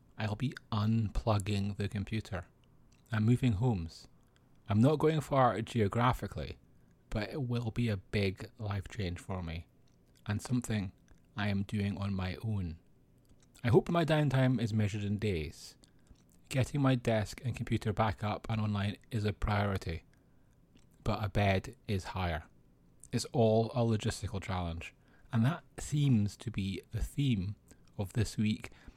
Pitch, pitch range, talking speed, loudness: 110 Hz, 100-120 Hz, 145 wpm, -34 LUFS